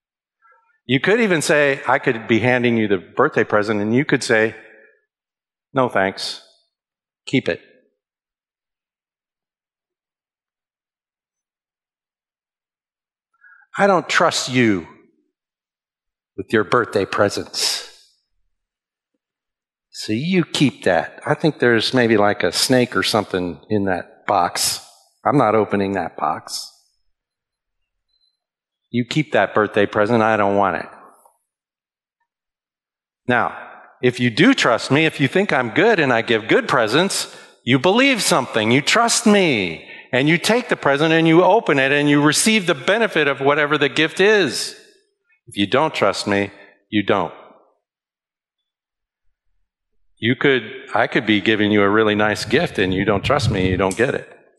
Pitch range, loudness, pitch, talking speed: 105-165 Hz, -17 LUFS, 125 Hz, 140 wpm